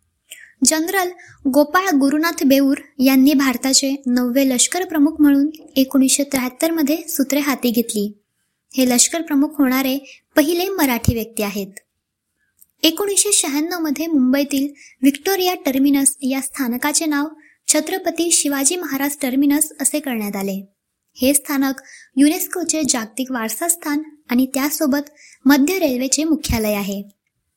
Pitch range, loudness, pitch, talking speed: 265-310 Hz, -17 LUFS, 280 Hz, 115 wpm